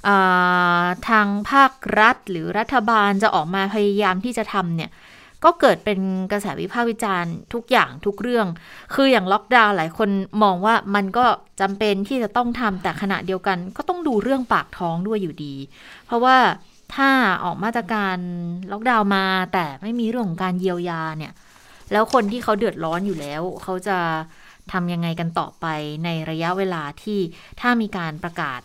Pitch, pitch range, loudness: 195 Hz, 175-225 Hz, -20 LUFS